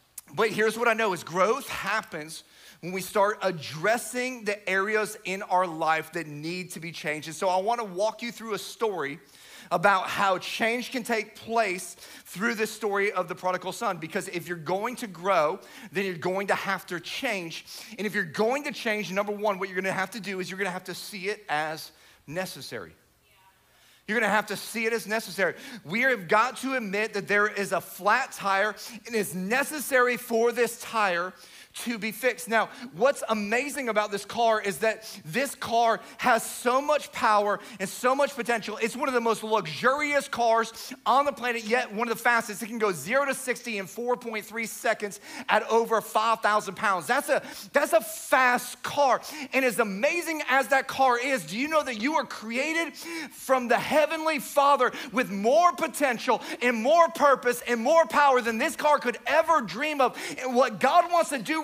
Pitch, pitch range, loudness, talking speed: 225 Hz, 195-255 Hz, -26 LUFS, 200 wpm